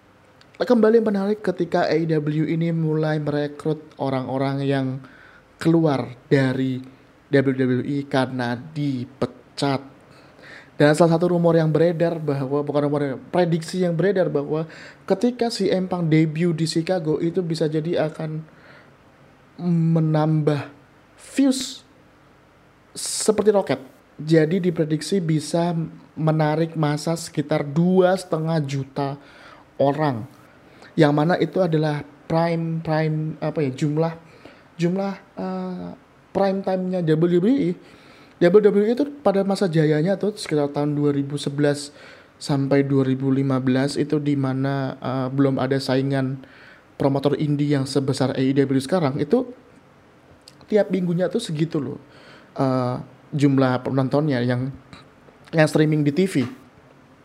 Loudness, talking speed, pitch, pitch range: -22 LUFS, 105 wpm, 150 Hz, 135-170 Hz